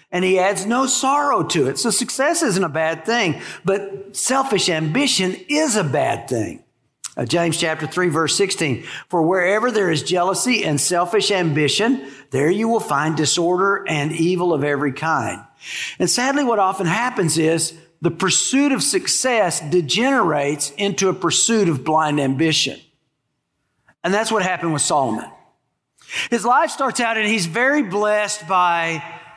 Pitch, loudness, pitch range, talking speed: 185 Hz, -18 LUFS, 160-225 Hz, 155 wpm